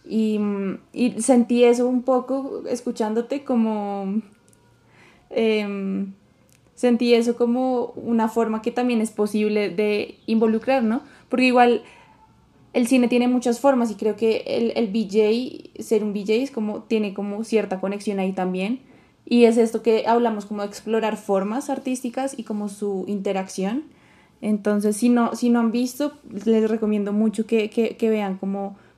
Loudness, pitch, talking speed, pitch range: -22 LUFS, 225 Hz, 150 wpm, 210-245 Hz